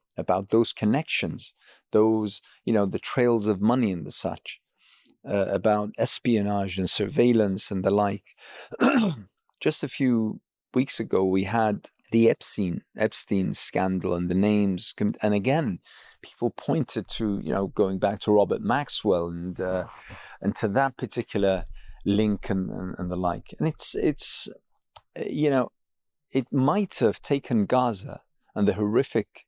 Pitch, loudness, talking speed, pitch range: 105 Hz, -25 LUFS, 145 wpm, 95-120 Hz